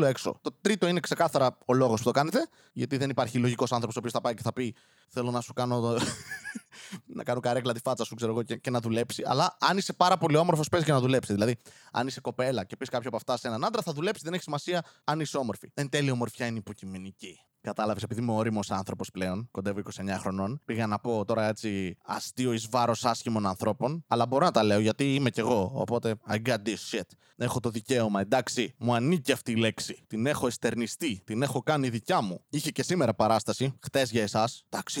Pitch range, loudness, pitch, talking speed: 110-135 Hz, -29 LUFS, 120 Hz, 225 wpm